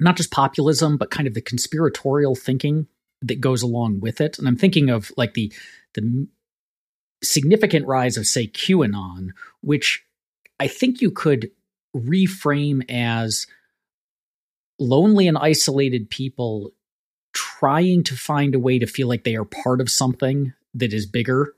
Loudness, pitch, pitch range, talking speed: -20 LUFS, 135 Hz, 120-155 Hz, 145 wpm